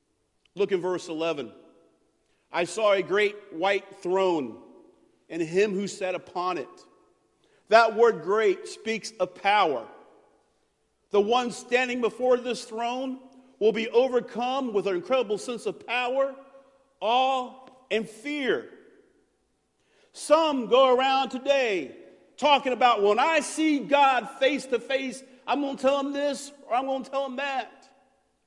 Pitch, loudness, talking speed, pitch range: 255 Hz, -25 LUFS, 140 wpm, 215-280 Hz